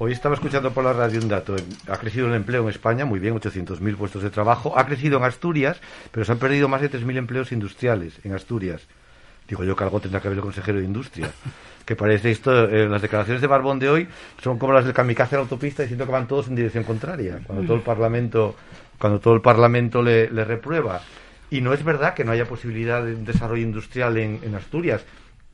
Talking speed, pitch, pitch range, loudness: 230 wpm, 115 Hz, 105-130 Hz, -22 LUFS